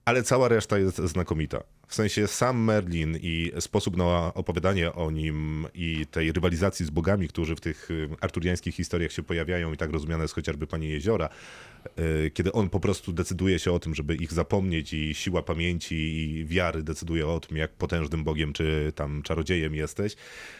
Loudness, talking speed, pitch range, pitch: -28 LUFS, 175 wpm, 80-90 Hz, 85 Hz